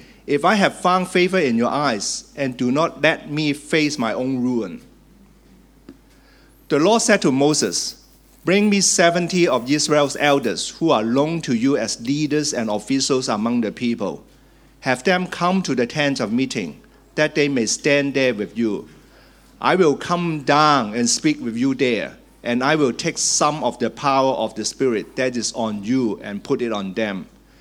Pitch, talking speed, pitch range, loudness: 145 Hz, 185 wpm, 125-180 Hz, -19 LUFS